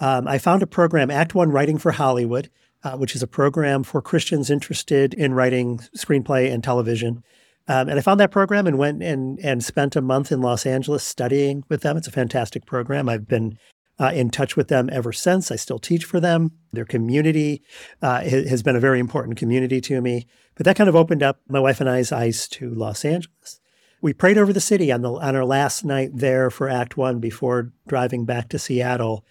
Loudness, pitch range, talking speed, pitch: -20 LUFS, 125-150 Hz, 215 wpm, 135 Hz